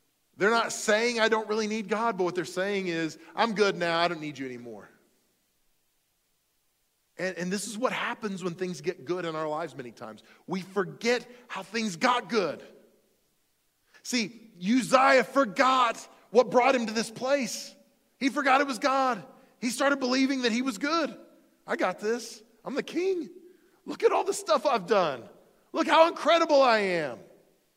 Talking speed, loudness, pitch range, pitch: 175 wpm, -27 LUFS, 185-265 Hz, 230 Hz